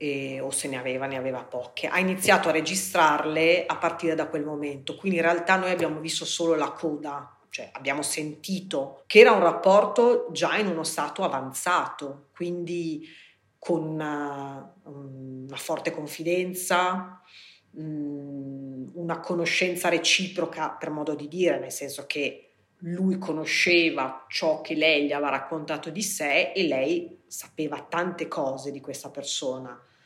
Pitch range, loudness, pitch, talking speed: 140-175 Hz, -25 LUFS, 160 Hz, 145 wpm